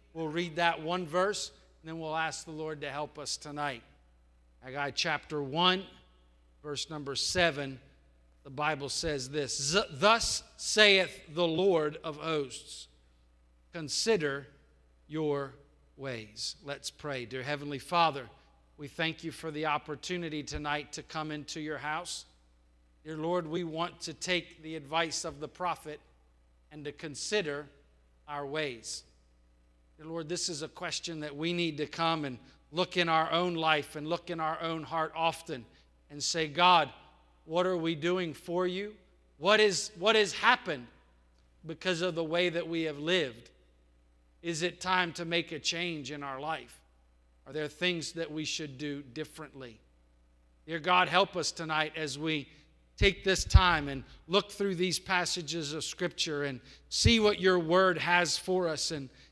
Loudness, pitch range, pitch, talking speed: -31 LUFS, 135-170 Hz, 155 Hz, 160 wpm